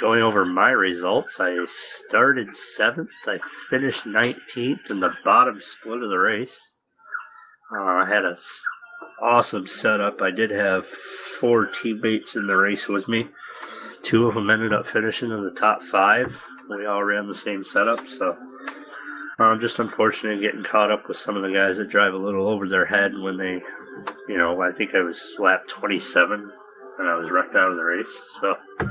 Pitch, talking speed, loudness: 110 Hz, 185 wpm, -22 LUFS